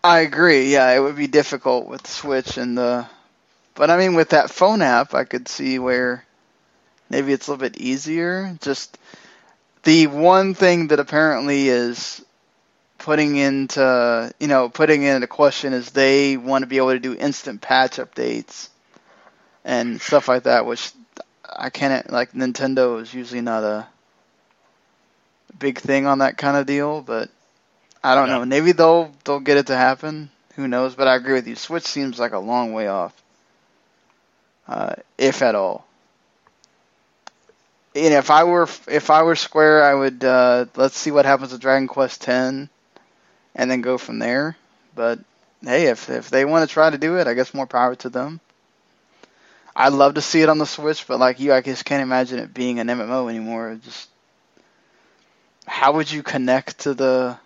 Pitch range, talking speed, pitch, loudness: 125-150 Hz, 180 wpm, 135 Hz, -18 LUFS